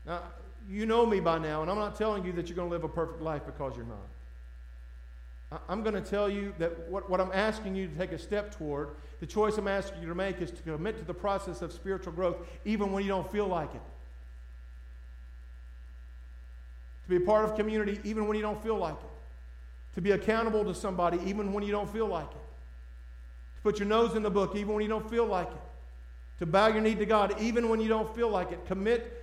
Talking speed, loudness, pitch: 235 wpm, -31 LUFS, 185 Hz